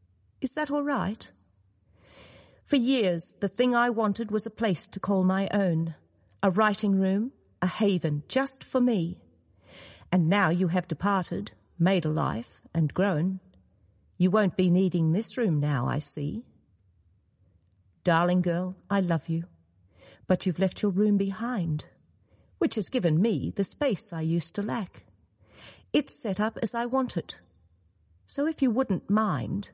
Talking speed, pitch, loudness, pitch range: 155 wpm, 185 Hz, -27 LUFS, 150-215 Hz